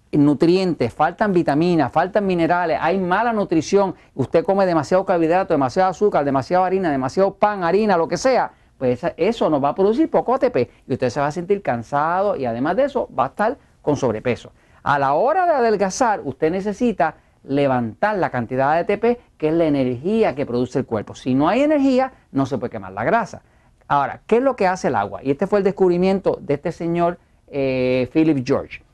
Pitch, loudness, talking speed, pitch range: 170 Hz, -19 LUFS, 195 wpm, 135-200 Hz